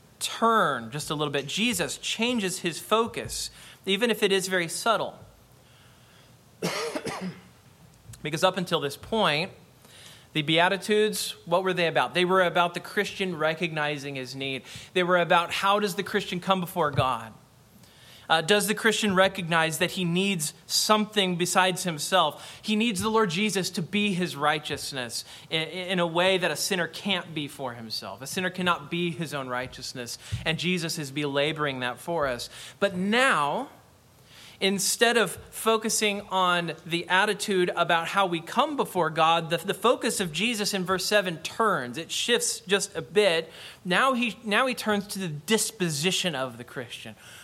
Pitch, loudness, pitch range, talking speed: 175 Hz, -26 LUFS, 150-200 Hz, 160 wpm